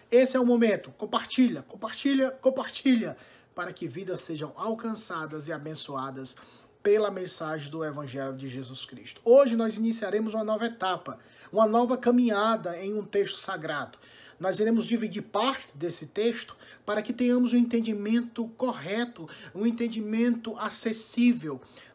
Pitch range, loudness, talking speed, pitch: 170-235 Hz, -28 LUFS, 135 wpm, 215 Hz